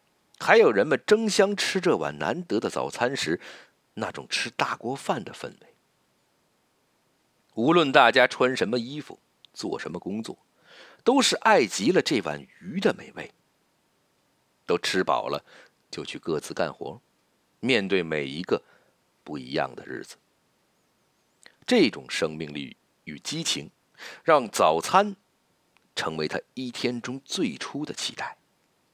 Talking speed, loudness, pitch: 190 characters per minute, -25 LUFS, 125 Hz